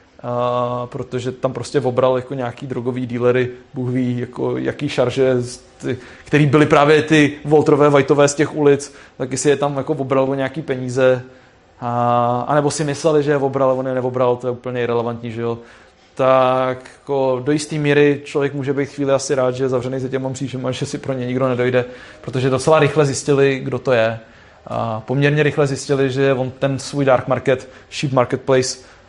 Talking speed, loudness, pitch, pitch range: 190 wpm, -18 LUFS, 130 Hz, 125-140 Hz